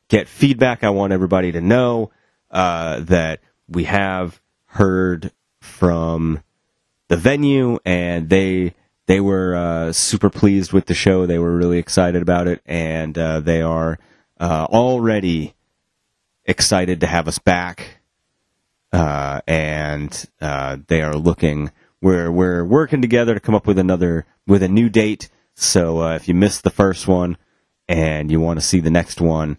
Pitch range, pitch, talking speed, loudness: 80-100 Hz, 90 Hz, 155 wpm, -17 LUFS